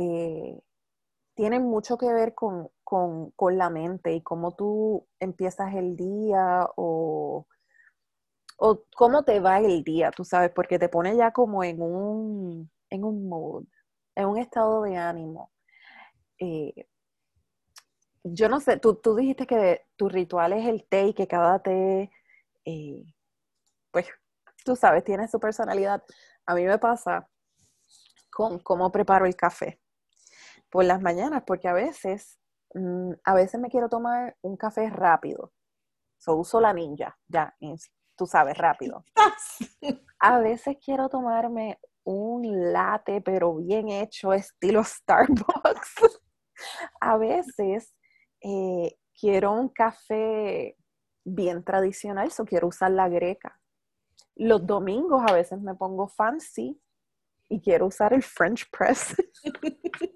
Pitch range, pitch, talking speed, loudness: 180-235 Hz, 200 Hz, 135 wpm, -25 LUFS